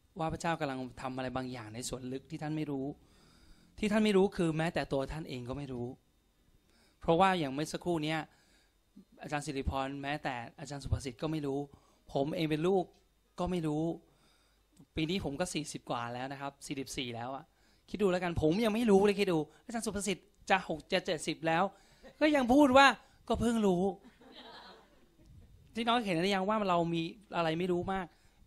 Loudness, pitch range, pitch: -33 LUFS, 140-195 Hz, 160 Hz